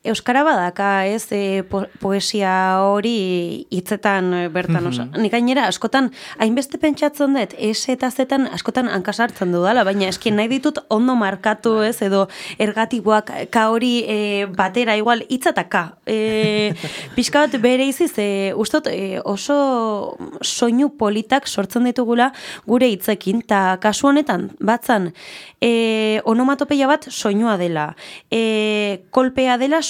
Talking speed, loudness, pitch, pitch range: 130 wpm, -18 LUFS, 220 Hz, 200-255 Hz